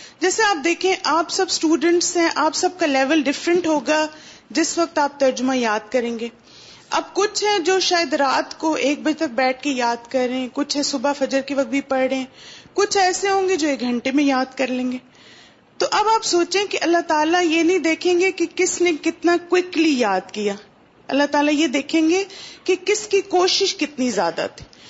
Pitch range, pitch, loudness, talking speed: 270-360 Hz, 315 Hz, -19 LUFS, 200 wpm